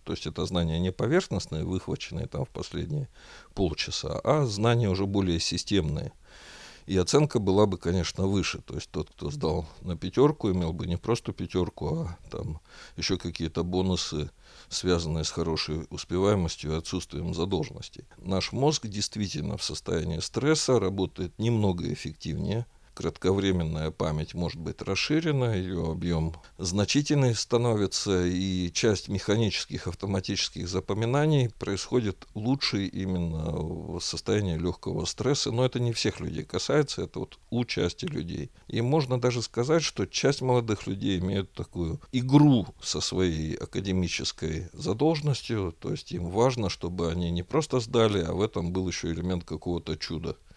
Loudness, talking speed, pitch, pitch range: -28 LUFS, 140 wpm, 95 Hz, 85-115 Hz